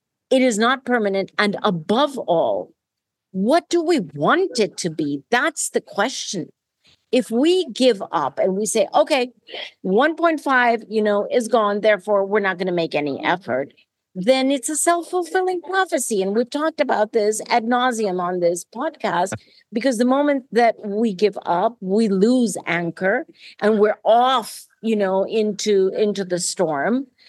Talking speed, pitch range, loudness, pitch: 160 wpm, 195-260 Hz, -20 LUFS, 220 Hz